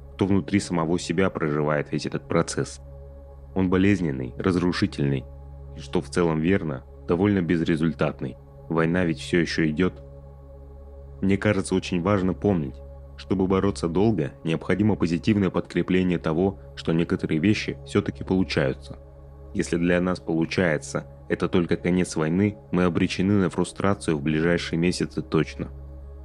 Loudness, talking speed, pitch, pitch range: -24 LUFS, 130 wpm, 85 Hz, 70-95 Hz